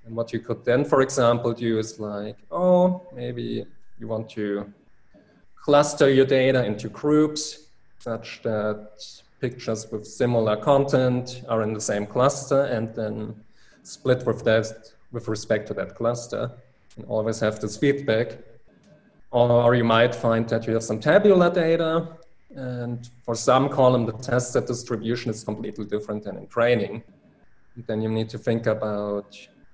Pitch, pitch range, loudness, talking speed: 115 Hz, 110-125 Hz, -23 LUFS, 155 wpm